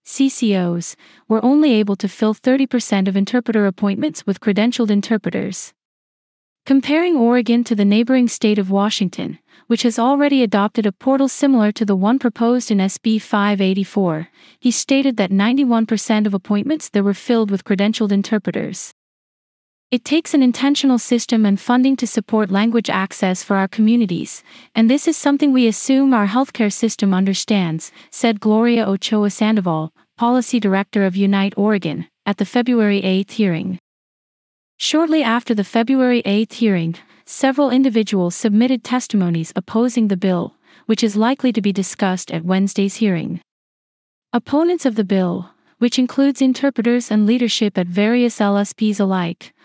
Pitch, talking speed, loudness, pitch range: 220 Hz, 145 wpm, -17 LUFS, 200-245 Hz